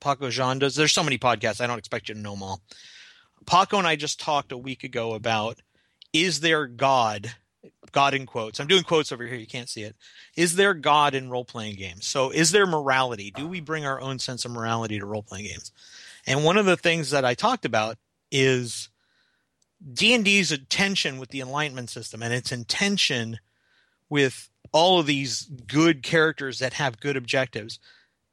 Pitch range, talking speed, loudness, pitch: 115-150 Hz, 190 wpm, -23 LUFS, 130 Hz